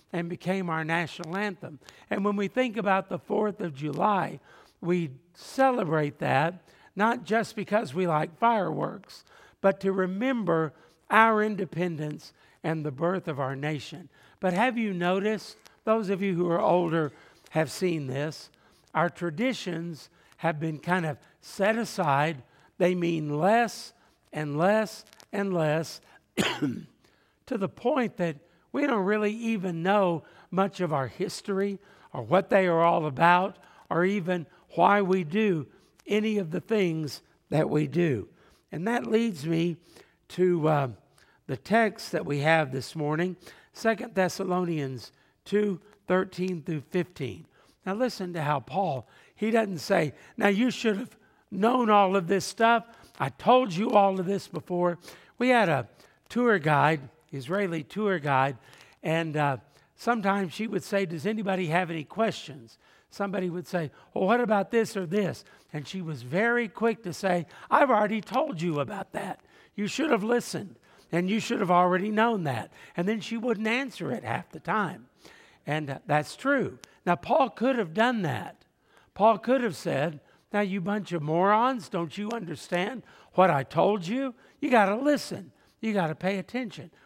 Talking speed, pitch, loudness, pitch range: 160 wpm, 185 Hz, -27 LUFS, 160-215 Hz